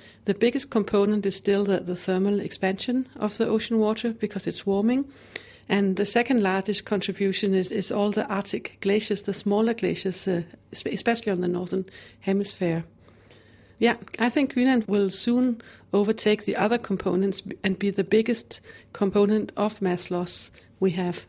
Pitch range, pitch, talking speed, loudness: 190-220 Hz, 200 Hz, 160 wpm, -25 LUFS